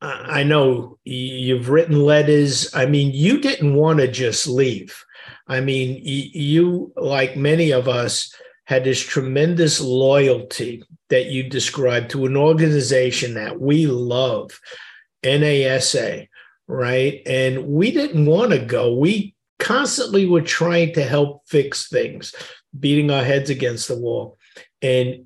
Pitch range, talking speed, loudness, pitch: 130-155 Hz, 135 wpm, -18 LUFS, 140 Hz